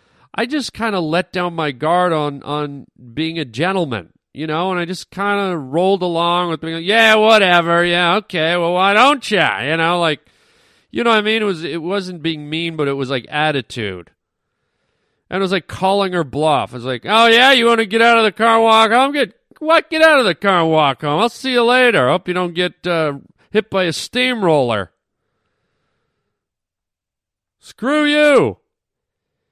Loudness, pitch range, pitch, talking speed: -15 LUFS, 155-220 Hz, 180 Hz, 205 wpm